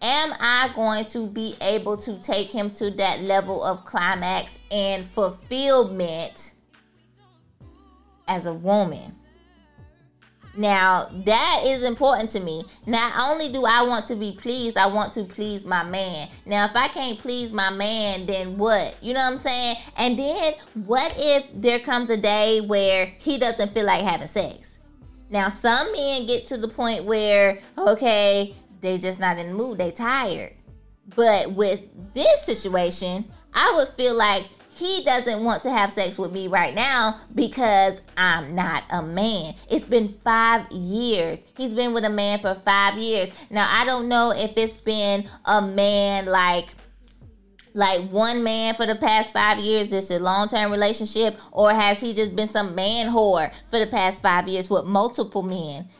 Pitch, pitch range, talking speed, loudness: 210 Hz, 195-235 Hz, 170 wpm, -21 LUFS